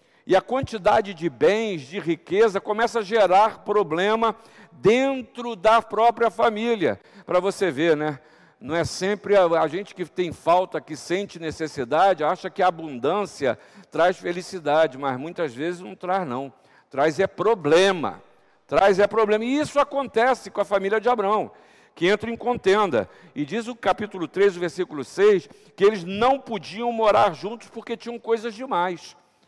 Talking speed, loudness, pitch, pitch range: 160 wpm, -22 LUFS, 200 Hz, 175-225 Hz